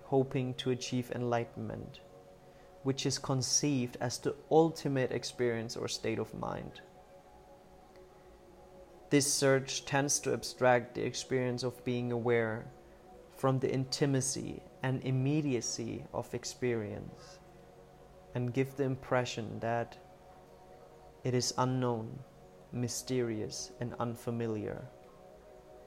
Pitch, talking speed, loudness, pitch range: 125 Hz, 100 wpm, -34 LUFS, 115-135 Hz